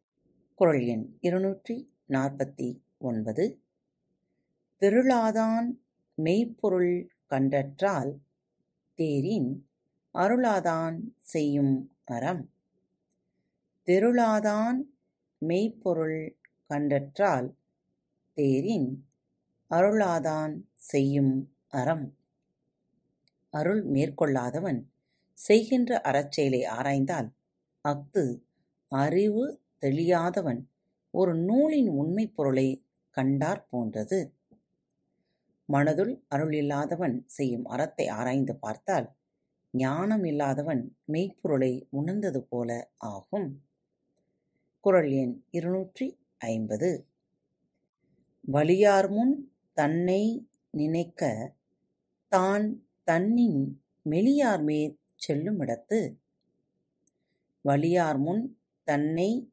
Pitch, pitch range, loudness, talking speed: 155 Hz, 135-200 Hz, -28 LUFS, 60 wpm